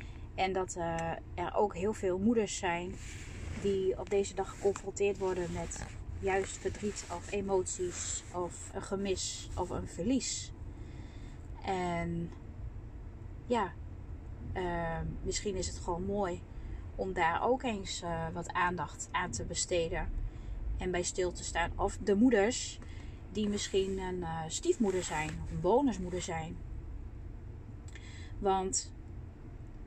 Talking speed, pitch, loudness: 125 wpm, 170 Hz, -35 LUFS